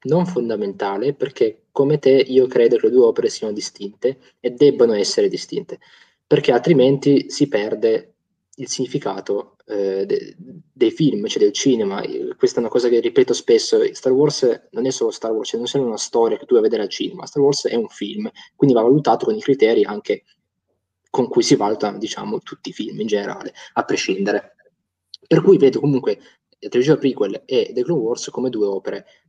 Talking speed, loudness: 195 wpm, -19 LUFS